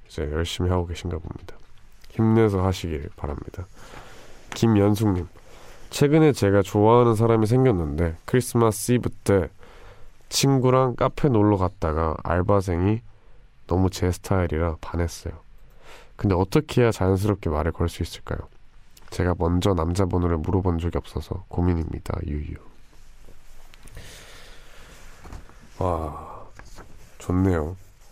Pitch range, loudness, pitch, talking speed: 85-110 Hz, -23 LUFS, 95 Hz, 265 characters per minute